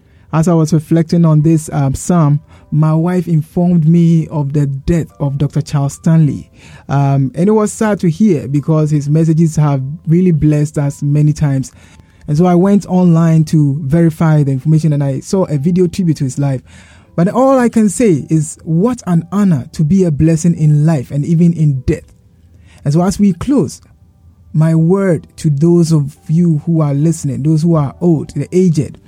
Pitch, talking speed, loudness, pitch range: 155 Hz, 190 wpm, -13 LUFS, 145-170 Hz